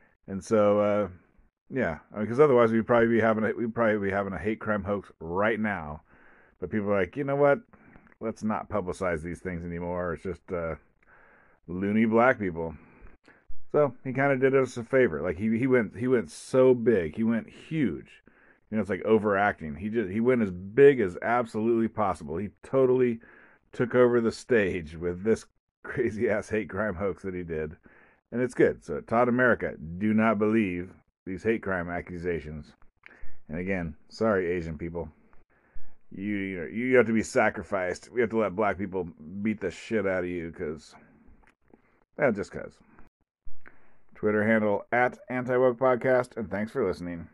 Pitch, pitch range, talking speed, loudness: 105 Hz, 90-120 Hz, 180 wpm, -27 LUFS